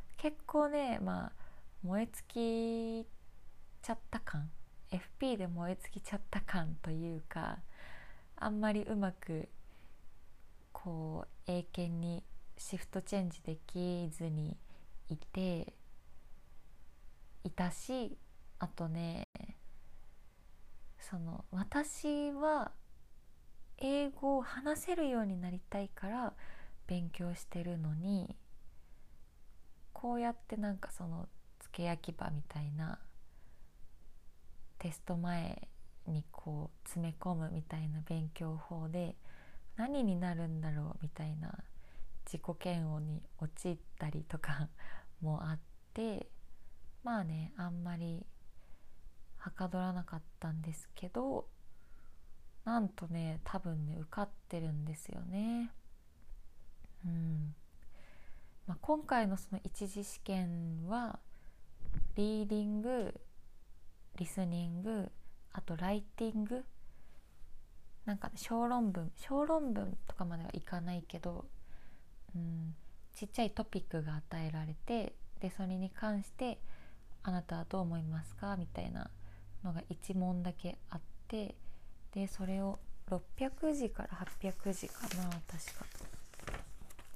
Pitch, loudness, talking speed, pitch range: 175 Hz, -41 LUFS, 205 characters per minute, 155-205 Hz